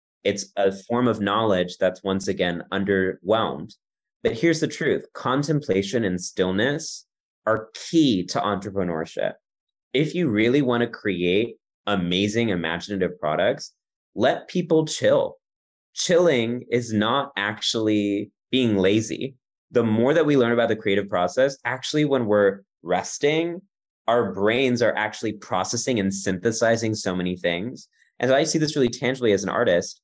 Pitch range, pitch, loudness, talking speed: 100-130 Hz, 110 Hz, -23 LUFS, 140 wpm